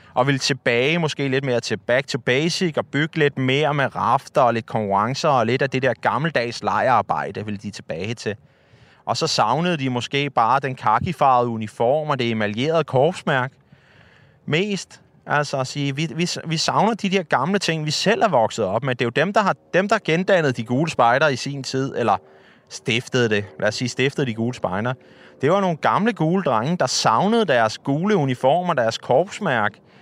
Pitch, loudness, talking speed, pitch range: 135 Hz, -20 LUFS, 195 wpm, 120-160 Hz